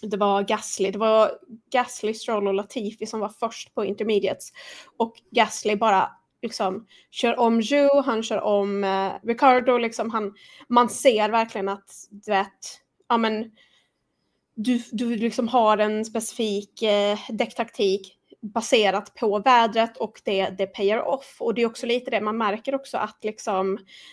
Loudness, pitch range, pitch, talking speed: -23 LUFS, 205-235 Hz, 220 Hz, 155 wpm